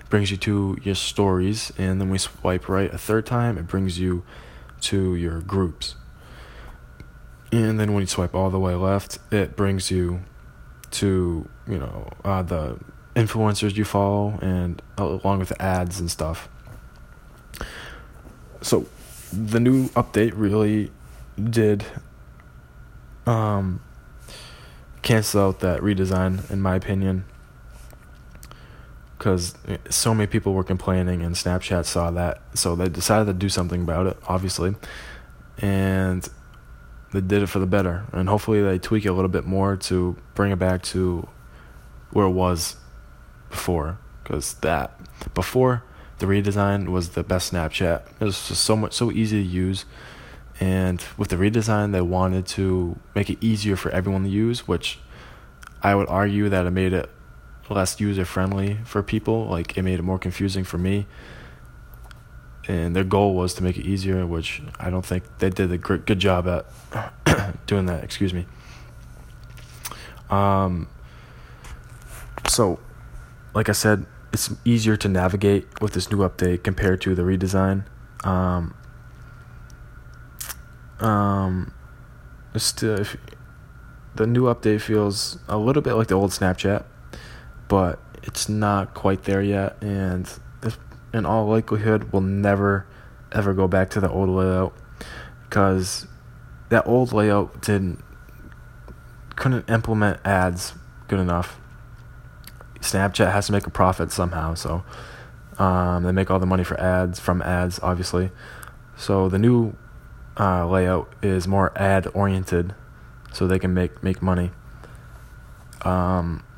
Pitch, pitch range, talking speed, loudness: 95 Hz, 90-100 Hz, 140 wpm, -23 LUFS